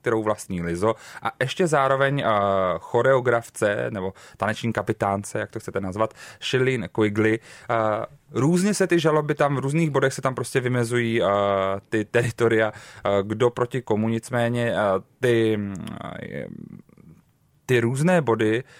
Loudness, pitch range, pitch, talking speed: -23 LUFS, 105-130 Hz, 115 Hz, 120 wpm